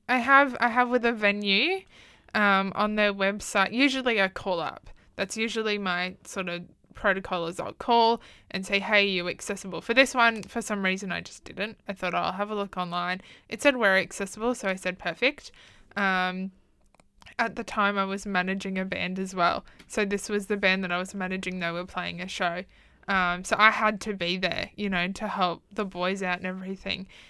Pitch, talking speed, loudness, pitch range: 195 Hz, 210 wpm, -26 LUFS, 185-215 Hz